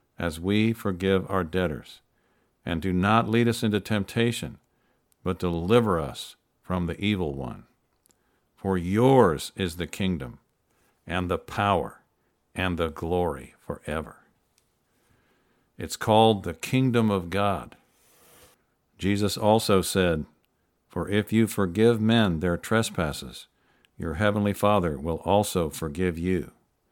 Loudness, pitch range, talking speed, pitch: -25 LUFS, 90-110 Hz, 120 wpm, 95 Hz